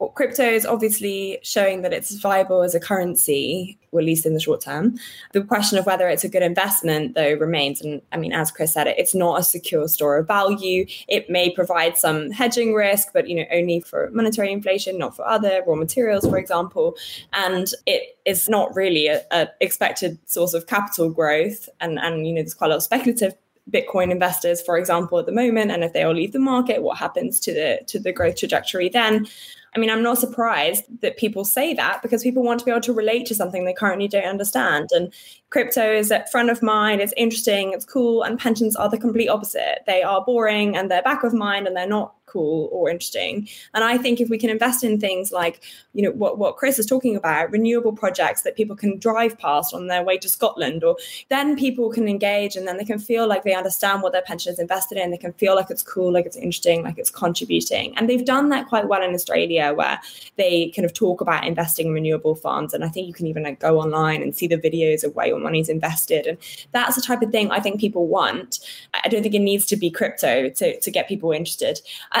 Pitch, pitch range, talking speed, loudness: 200 Hz, 175-235 Hz, 235 wpm, -20 LUFS